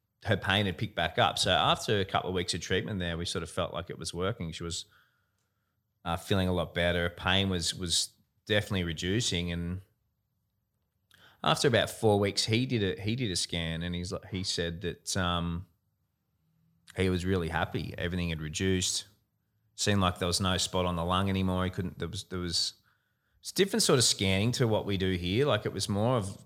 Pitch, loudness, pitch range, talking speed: 95 Hz, -30 LUFS, 90-105 Hz, 210 wpm